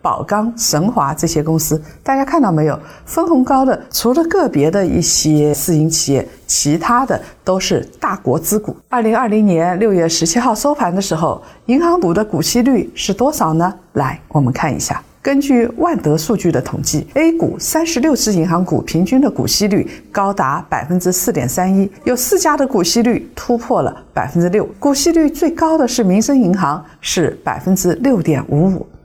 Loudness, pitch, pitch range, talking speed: -15 LUFS, 205 Hz, 165-265 Hz, 280 characters per minute